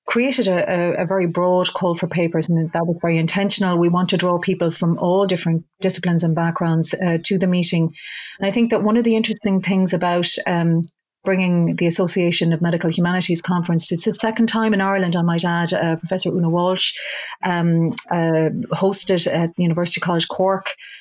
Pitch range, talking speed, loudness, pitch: 170-190 Hz, 190 wpm, -19 LUFS, 175 Hz